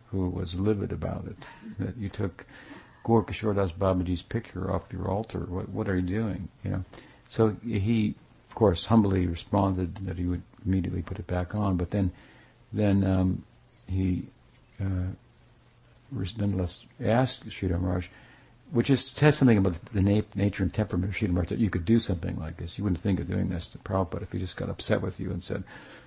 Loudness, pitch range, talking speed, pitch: -29 LUFS, 90-110 Hz, 190 wpm, 95 Hz